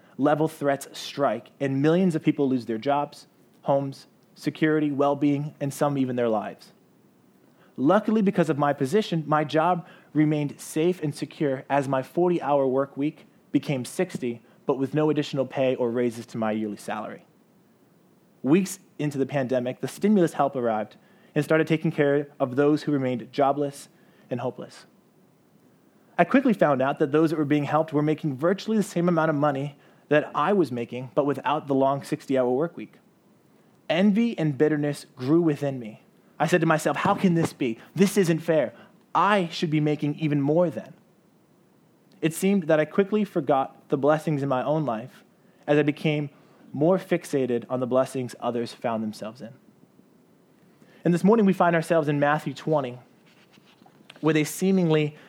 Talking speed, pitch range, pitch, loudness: 170 wpm, 140-170 Hz, 150 Hz, -25 LUFS